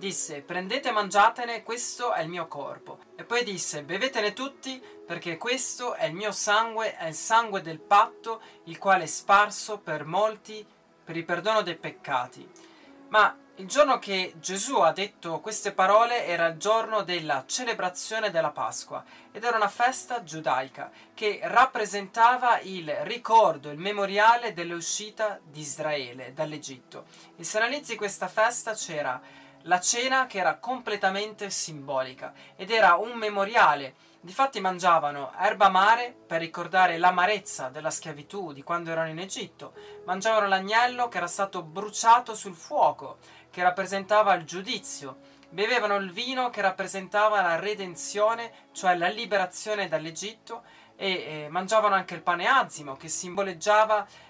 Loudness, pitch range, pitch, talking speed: -26 LUFS, 170-220 Hz, 195 Hz, 145 wpm